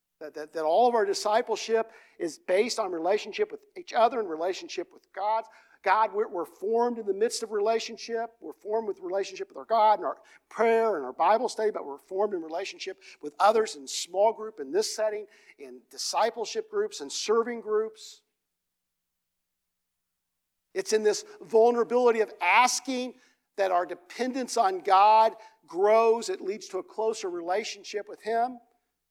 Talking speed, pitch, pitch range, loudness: 165 wpm, 225 Hz, 195-250 Hz, -27 LUFS